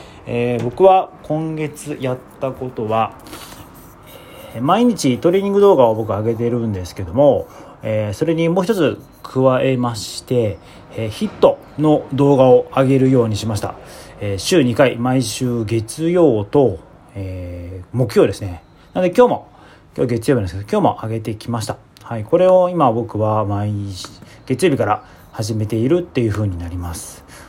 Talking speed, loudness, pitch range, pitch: 305 characters per minute, -17 LUFS, 105-140 Hz, 120 Hz